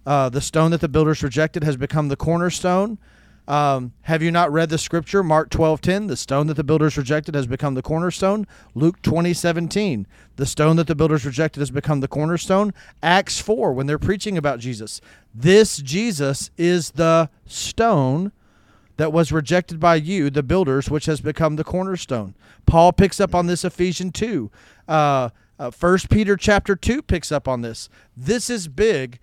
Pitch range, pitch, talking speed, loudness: 140-180 Hz, 160 Hz, 180 wpm, -20 LUFS